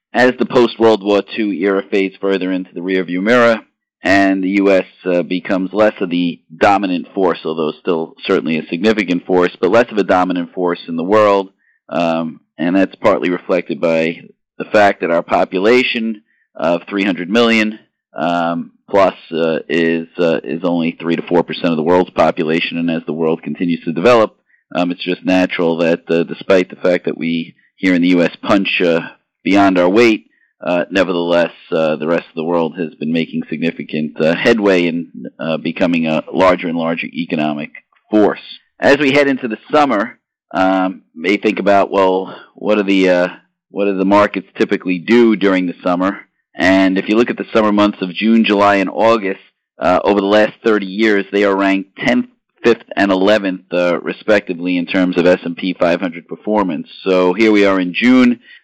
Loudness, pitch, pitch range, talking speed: -15 LUFS, 95 Hz, 85-105 Hz, 185 wpm